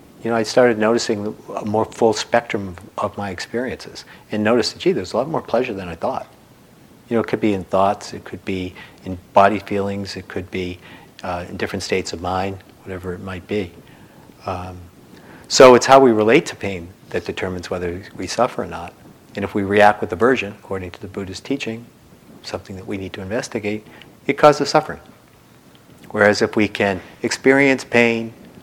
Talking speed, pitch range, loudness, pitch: 195 wpm, 95-115 Hz, -19 LUFS, 100 Hz